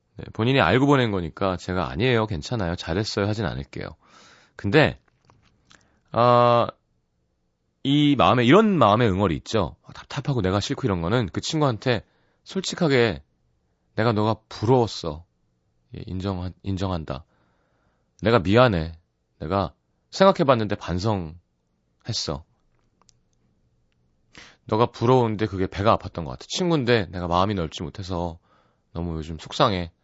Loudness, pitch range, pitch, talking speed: -22 LUFS, 85-120 Hz, 100 Hz, 275 characters per minute